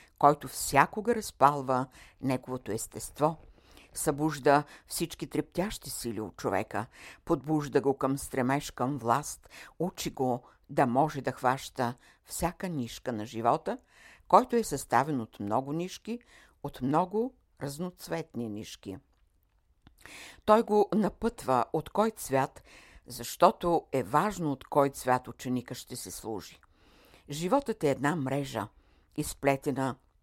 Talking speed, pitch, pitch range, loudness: 115 wpm, 140 Hz, 120-165 Hz, -30 LUFS